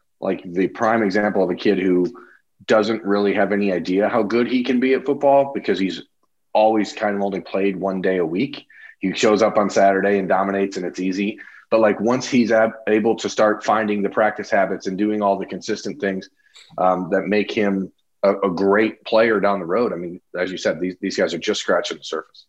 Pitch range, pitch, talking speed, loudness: 95-110 Hz, 100 Hz, 220 wpm, -20 LUFS